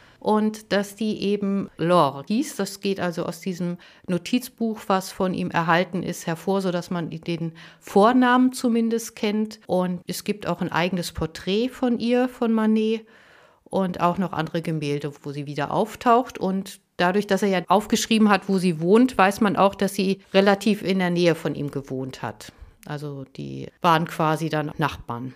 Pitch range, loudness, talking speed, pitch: 170-215 Hz, -23 LUFS, 175 wpm, 185 Hz